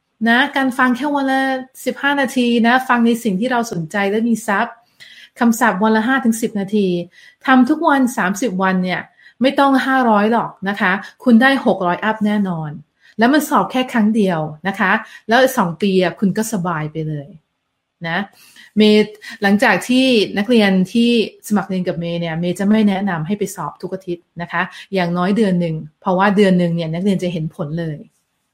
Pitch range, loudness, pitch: 180-240 Hz, -16 LUFS, 205 Hz